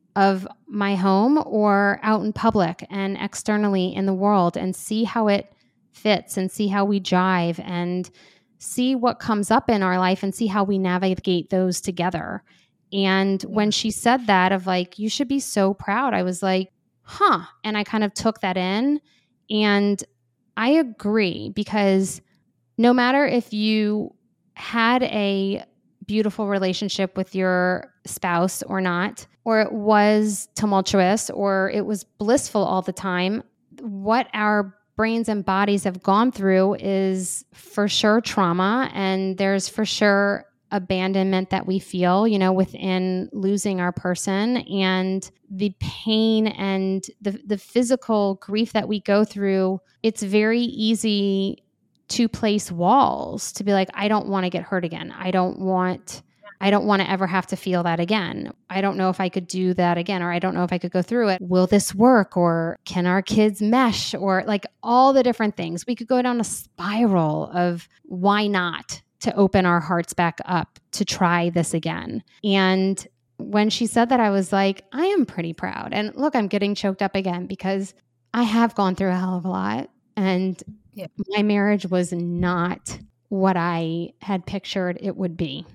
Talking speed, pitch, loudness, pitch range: 175 wpm, 195 Hz, -22 LUFS, 185-215 Hz